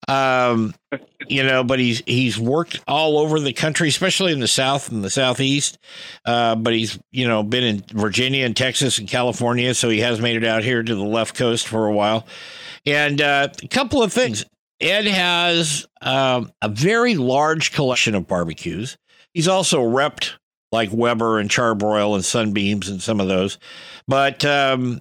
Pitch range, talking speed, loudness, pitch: 110-145 Hz, 180 wpm, -19 LUFS, 125 Hz